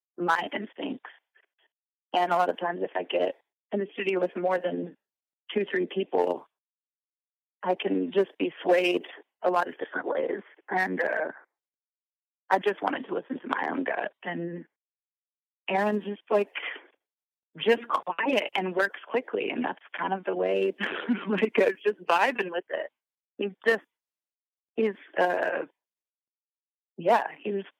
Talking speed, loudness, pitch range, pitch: 150 wpm, -28 LUFS, 175-210 Hz, 195 Hz